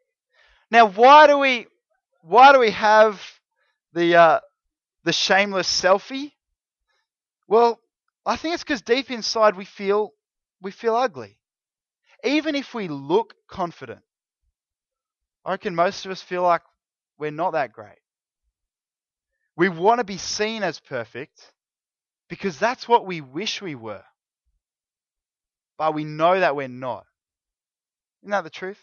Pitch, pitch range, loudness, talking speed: 205 Hz, 175-250 Hz, -20 LUFS, 135 wpm